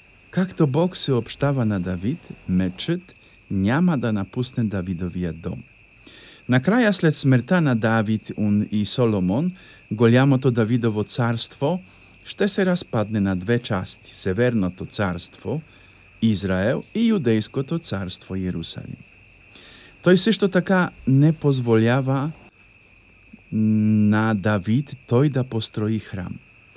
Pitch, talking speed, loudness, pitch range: 115 Hz, 110 wpm, -21 LUFS, 100-140 Hz